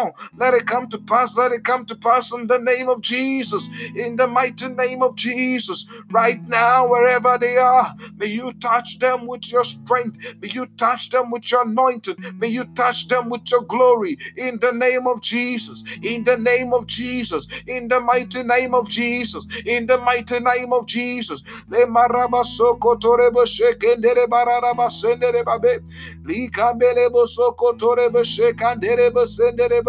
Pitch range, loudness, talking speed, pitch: 235-255 Hz, -18 LUFS, 140 wpm, 245 Hz